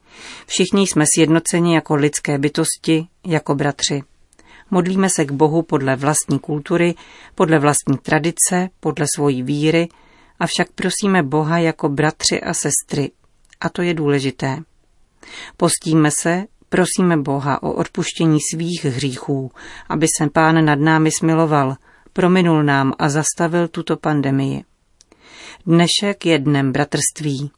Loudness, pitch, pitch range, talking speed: -17 LUFS, 155 Hz, 145-170 Hz, 125 wpm